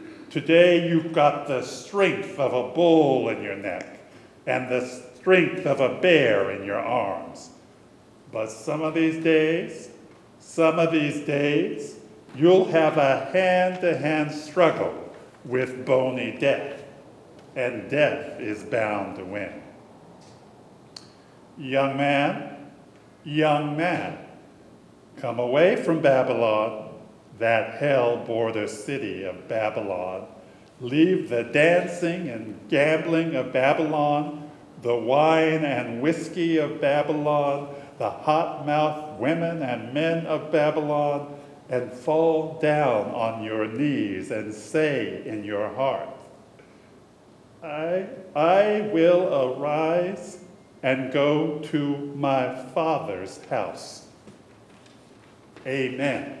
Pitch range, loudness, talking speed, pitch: 130-165 Hz, -24 LUFS, 110 wpm, 150 Hz